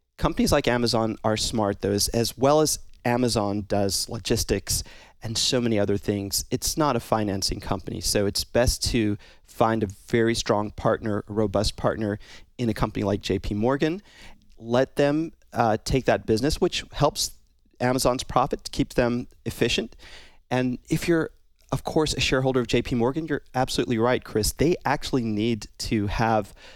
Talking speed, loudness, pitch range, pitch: 165 wpm, -25 LUFS, 105-125 Hz, 115 Hz